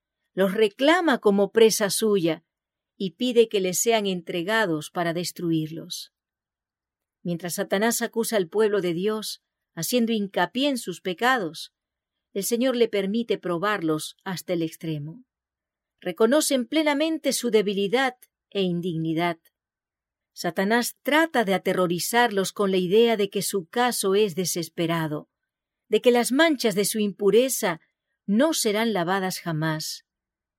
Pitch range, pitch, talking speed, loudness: 180-235 Hz, 205 Hz, 125 wpm, -24 LUFS